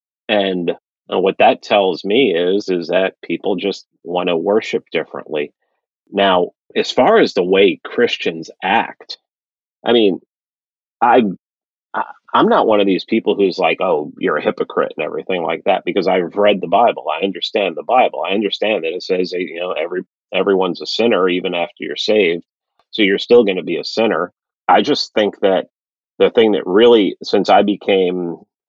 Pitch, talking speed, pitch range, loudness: 95 Hz, 180 wpm, 90-105 Hz, -16 LUFS